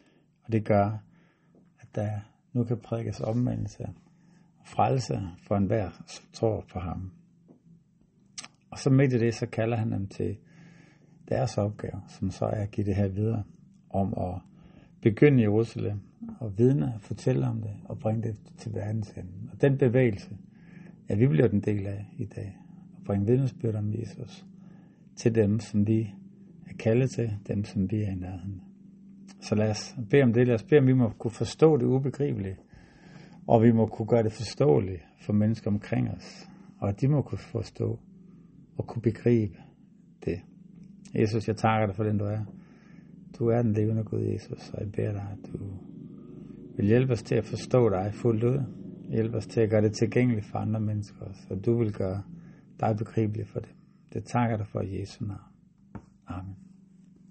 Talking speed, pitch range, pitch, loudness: 185 wpm, 105-140 Hz, 115 Hz, -28 LUFS